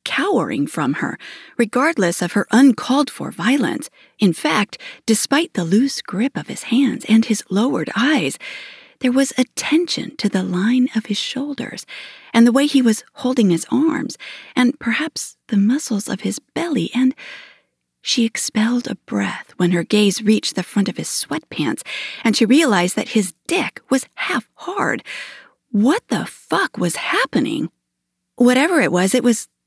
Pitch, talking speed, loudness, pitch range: 235 Hz, 160 wpm, -18 LUFS, 205-270 Hz